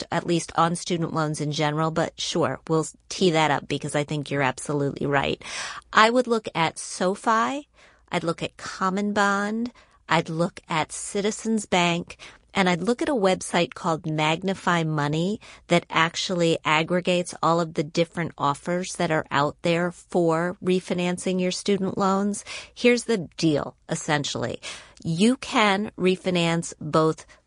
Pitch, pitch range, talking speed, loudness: 175 Hz, 160-195 Hz, 150 wpm, -24 LUFS